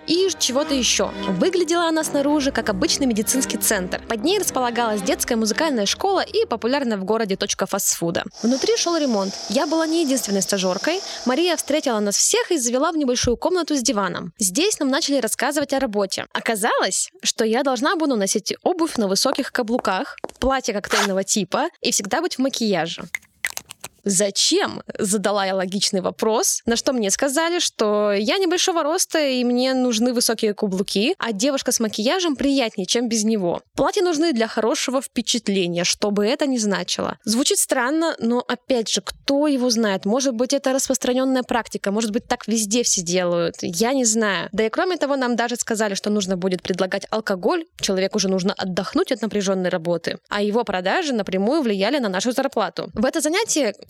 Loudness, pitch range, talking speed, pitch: -20 LUFS, 205-285 Hz, 170 wpm, 240 Hz